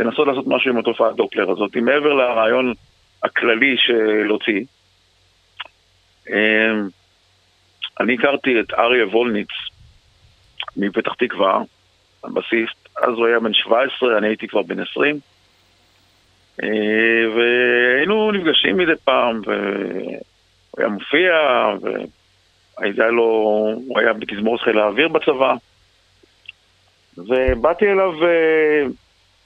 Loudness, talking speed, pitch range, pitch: -17 LUFS, 95 wpm, 95-125 Hz, 110 Hz